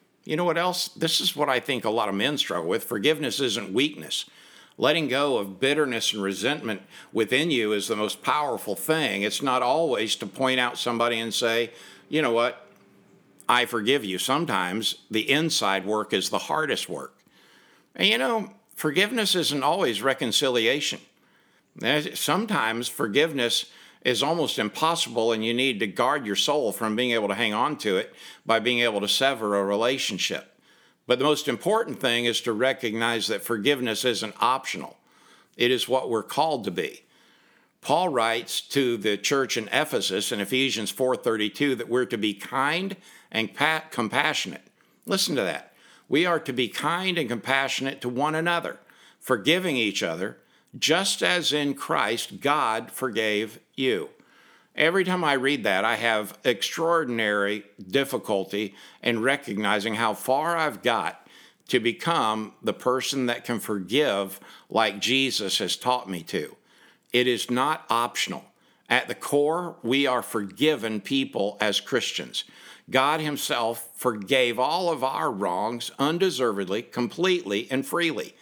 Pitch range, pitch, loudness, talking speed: 110-145 Hz, 125 Hz, -25 LUFS, 150 wpm